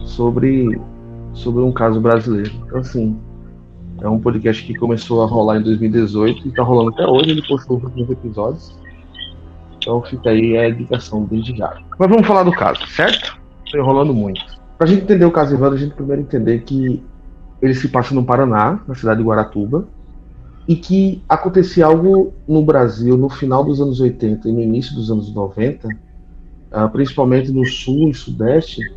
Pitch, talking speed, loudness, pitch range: 120 Hz, 175 wpm, -15 LUFS, 110-135 Hz